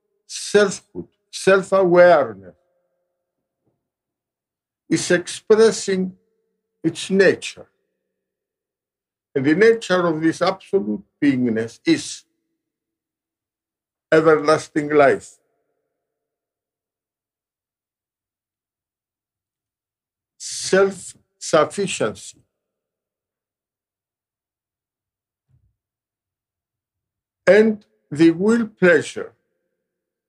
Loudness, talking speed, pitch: -18 LUFS, 45 wpm, 175 Hz